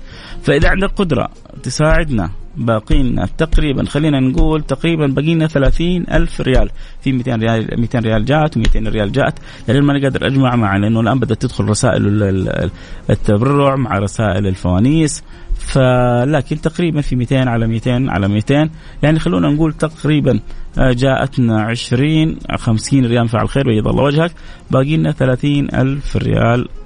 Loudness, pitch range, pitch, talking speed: -15 LUFS, 115-150 Hz, 130 Hz, 140 wpm